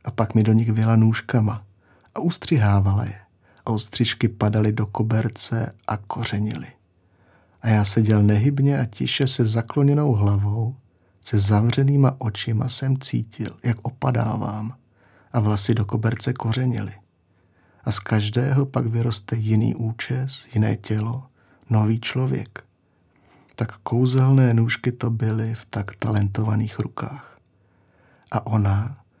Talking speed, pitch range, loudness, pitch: 125 wpm, 105-125 Hz, -22 LUFS, 110 Hz